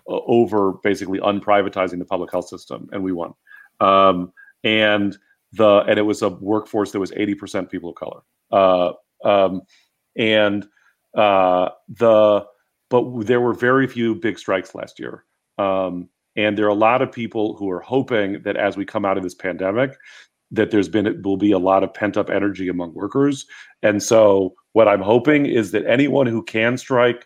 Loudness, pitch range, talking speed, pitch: -19 LUFS, 95-115 Hz, 185 wpm, 100 Hz